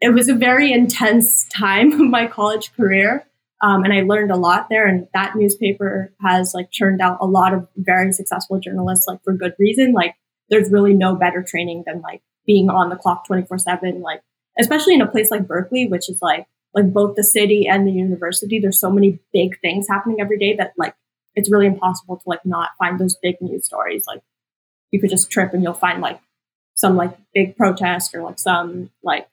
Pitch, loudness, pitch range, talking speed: 195 Hz, -17 LUFS, 180-210 Hz, 210 wpm